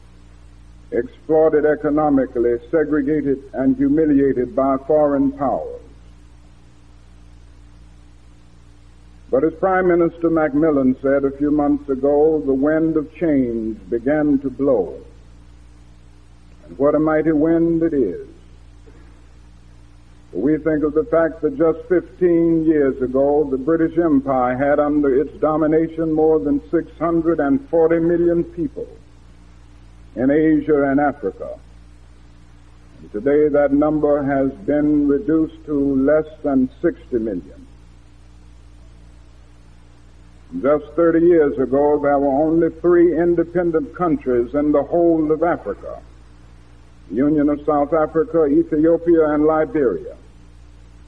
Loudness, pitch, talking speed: -18 LUFS, 140 Hz, 110 wpm